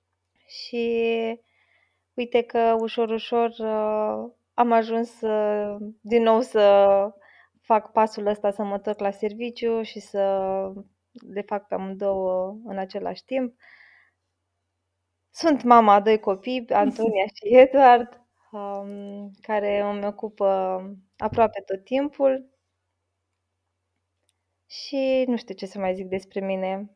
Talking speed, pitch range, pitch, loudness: 110 wpm, 195-230 Hz, 210 Hz, -23 LUFS